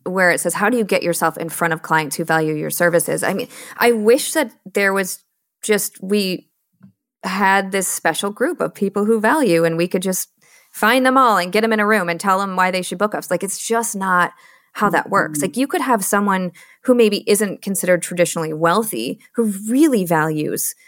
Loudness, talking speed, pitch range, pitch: -18 LUFS, 215 wpm, 175-220 Hz, 195 Hz